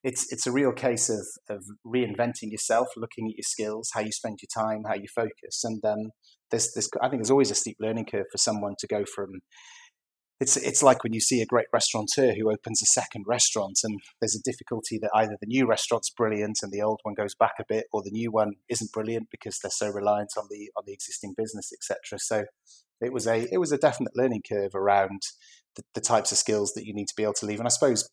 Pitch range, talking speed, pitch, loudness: 105-115 Hz, 245 wpm, 110 Hz, -27 LUFS